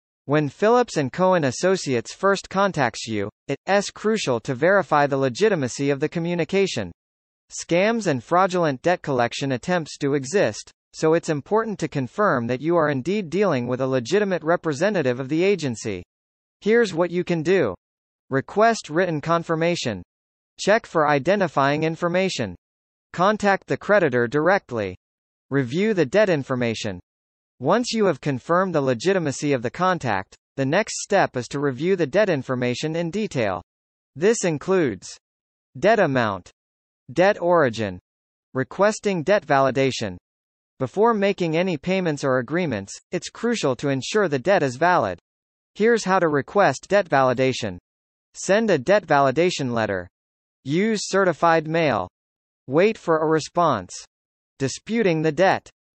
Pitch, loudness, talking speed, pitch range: 155 Hz, -22 LUFS, 135 wpm, 125-185 Hz